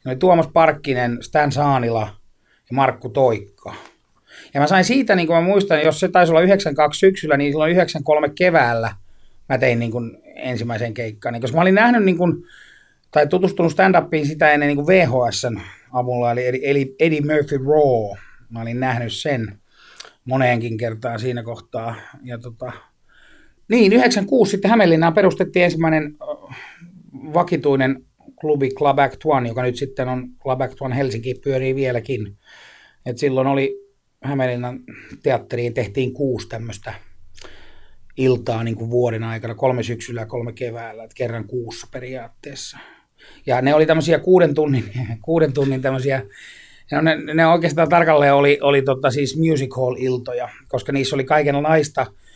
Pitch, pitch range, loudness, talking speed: 135 Hz, 120-155 Hz, -18 LUFS, 140 wpm